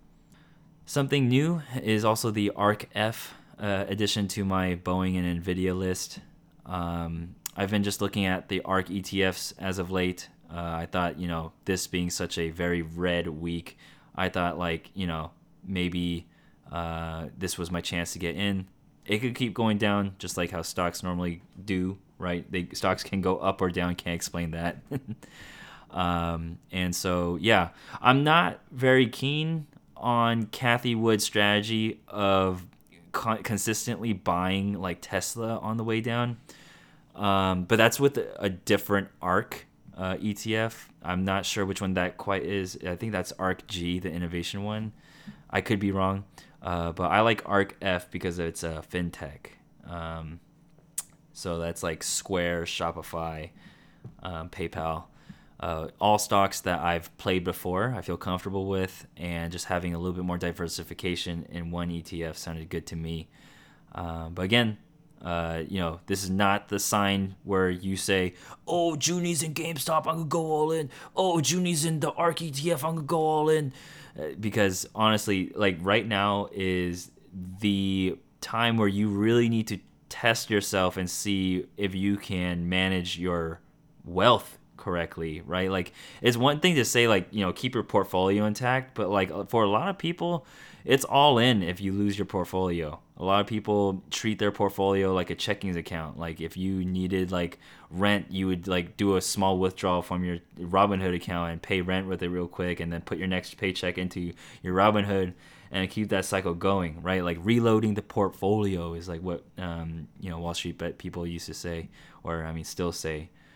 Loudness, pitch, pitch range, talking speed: -28 LUFS, 95 Hz, 85-105 Hz, 175 wpm